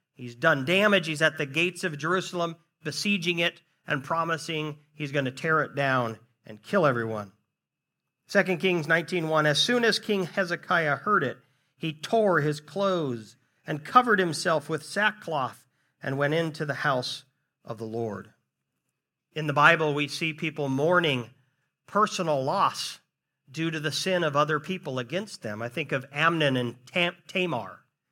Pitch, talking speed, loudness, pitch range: 155 Hz, 160 wpm, -26 LUFS, 140-175 Hz